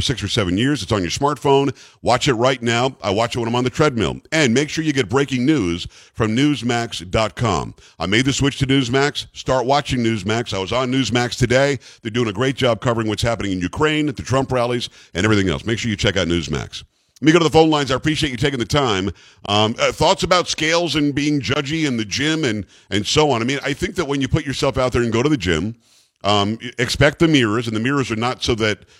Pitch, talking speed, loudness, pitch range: 125 Hz, 250 wpm, -19 LUFS, 110-140 Hz